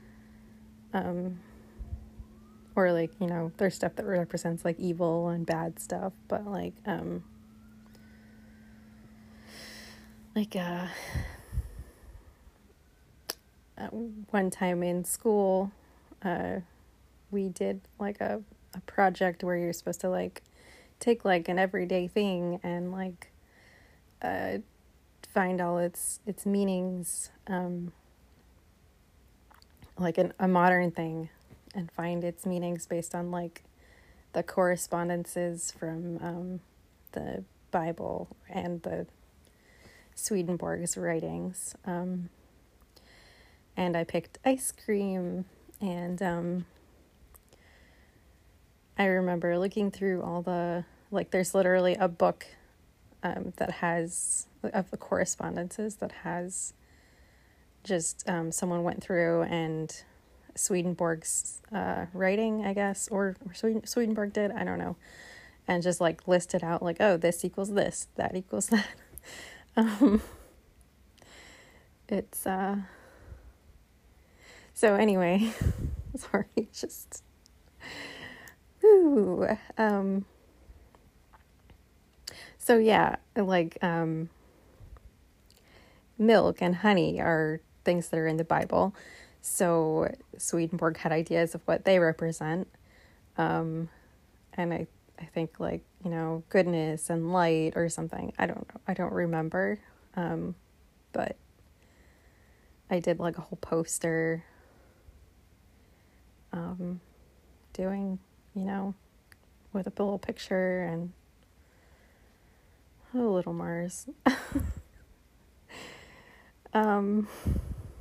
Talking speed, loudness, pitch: 100 wpm, -30 LUFS, 175 Hz